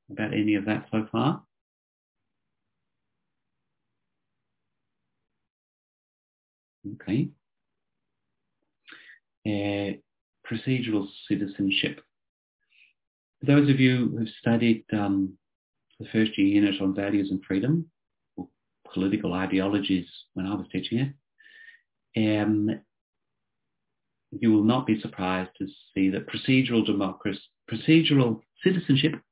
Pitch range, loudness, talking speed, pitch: 95-125 Hz, -26 LUFS, 95 wpm, 105 Hz